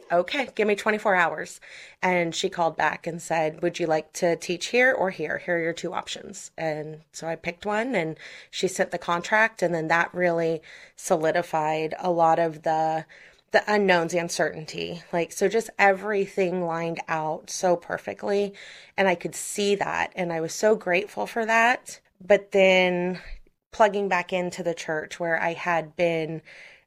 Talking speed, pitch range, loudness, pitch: 175 wpm, 165-195 Hz, -25 LUFS, 175 Hz